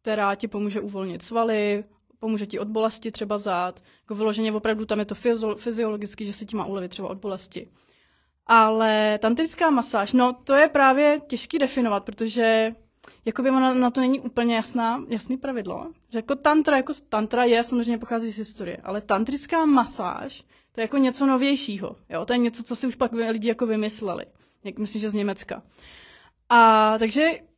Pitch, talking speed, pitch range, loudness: 225 Hz, 180 wpm, 215-250 Hz, -23 LUFS